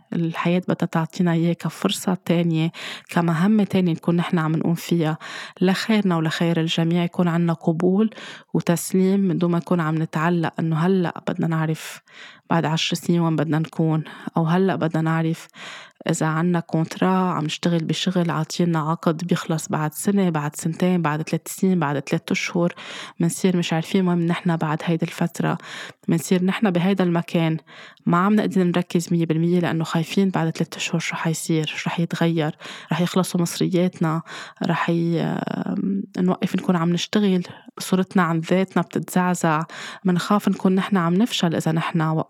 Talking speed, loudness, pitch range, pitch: 150 wpm, -22 LUFS, 165-185 Hz, 175 Hz